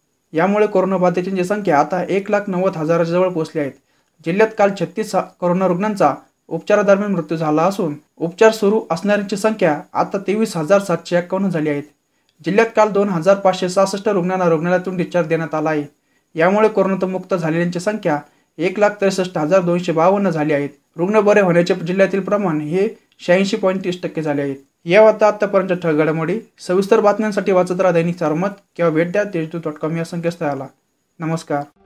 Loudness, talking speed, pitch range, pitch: -17 LUFS, 170 wpm, 165-200 Hz, 180 Hz